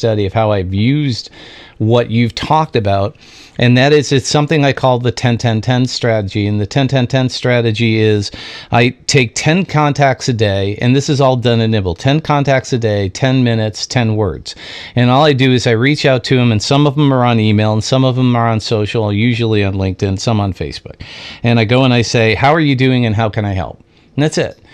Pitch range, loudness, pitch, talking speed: 110-130 Hz, -13 LUFS, 120 Hz, 225 wpm